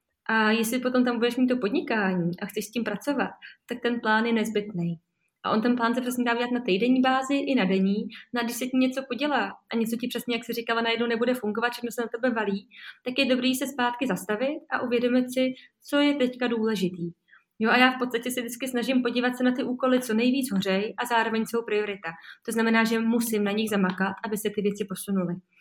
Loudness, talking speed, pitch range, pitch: -26 LUFS, 230 wpm, 215-250 Hz, 235 Hz